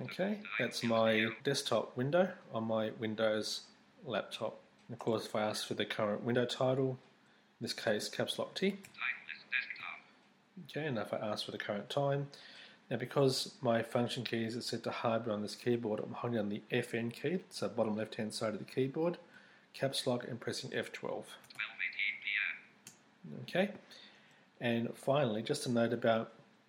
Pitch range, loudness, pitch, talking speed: 115-145 Hz, -36 LUFS, 120 Hz, 160 wpm